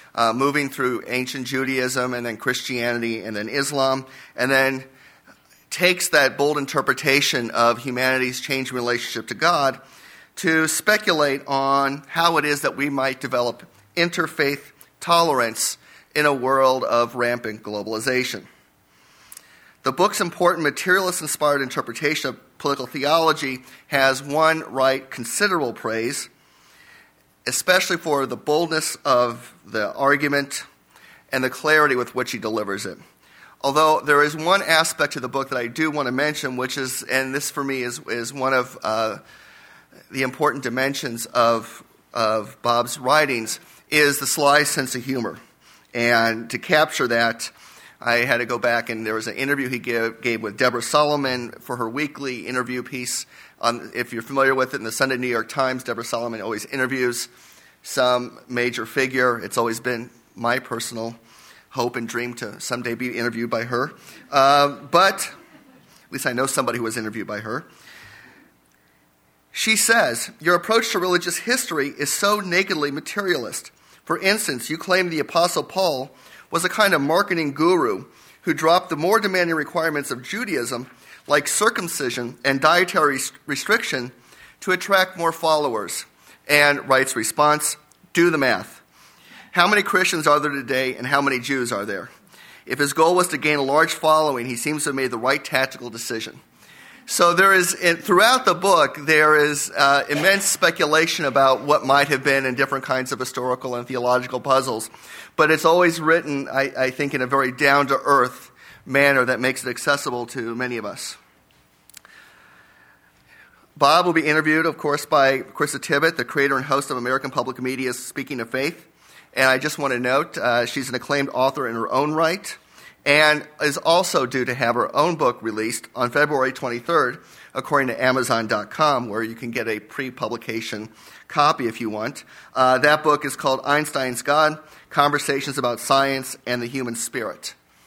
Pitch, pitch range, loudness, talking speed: 135 Hz, 125-150 Hz, -20 LUFS, 165 wpm